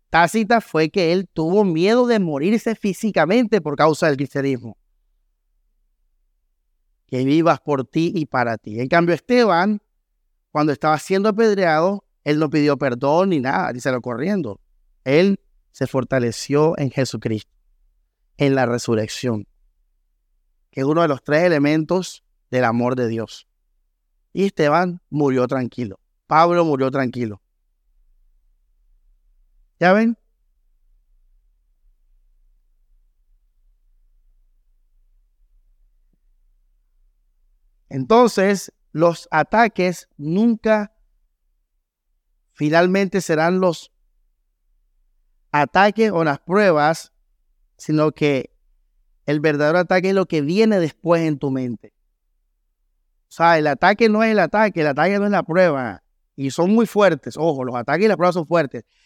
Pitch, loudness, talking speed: 140 Hz, -19 LUFS, 115 wpm